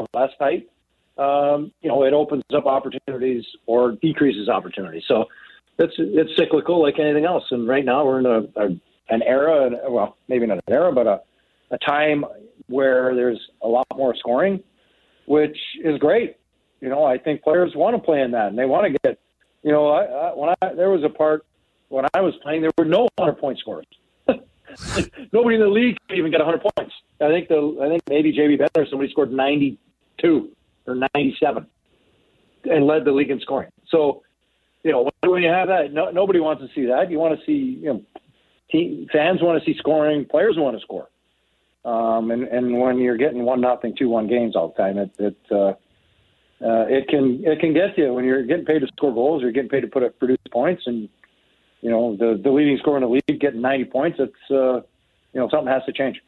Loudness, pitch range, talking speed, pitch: -20 LUFS, 125-160 Hz, 210 wpm, 145 Hz